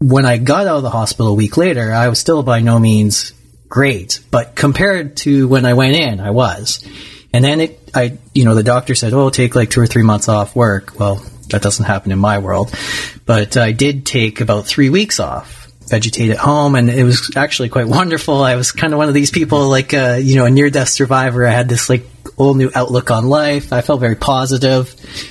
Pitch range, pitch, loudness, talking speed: 115-135 Hz, 125 Hz, -13 LUFS, 230 wpm